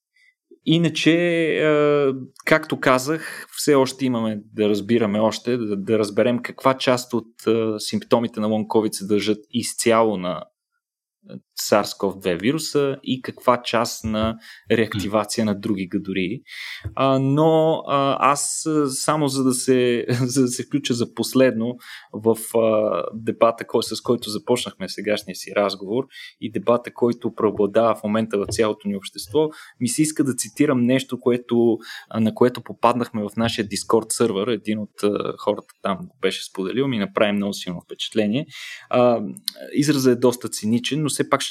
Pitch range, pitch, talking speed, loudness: 110-135 Hz, 120 Hz, 135 wpm, -21 LUFS